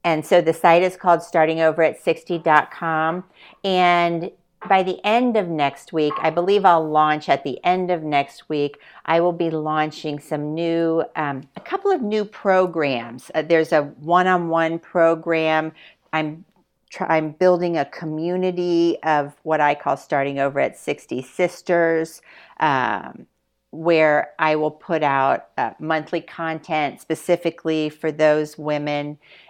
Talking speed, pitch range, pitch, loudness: 140 wpm, 155-175 Hz, 160 Hz, -20 LUFS